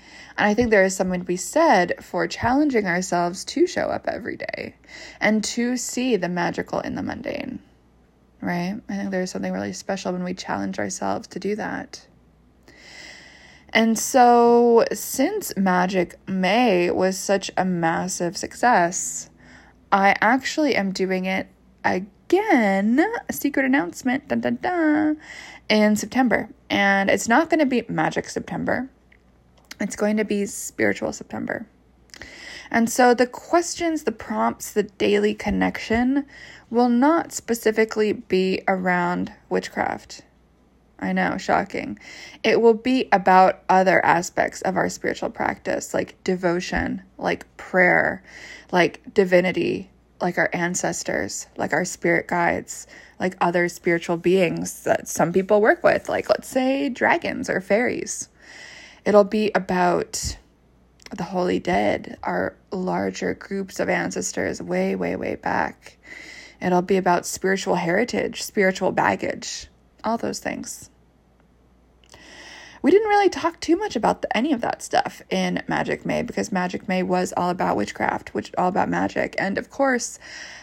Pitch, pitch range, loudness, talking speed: 195 Hz, 175-245 Hz, -22 LUFS, 140 wpm